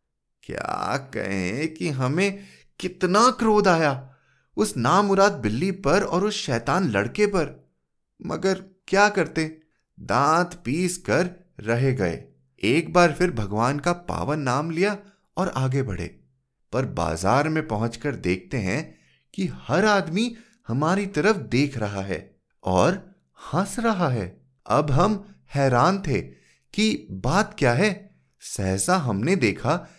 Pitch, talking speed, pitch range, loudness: 160 Hz, 130 wpm, 120-195 Hz, -23 LUFS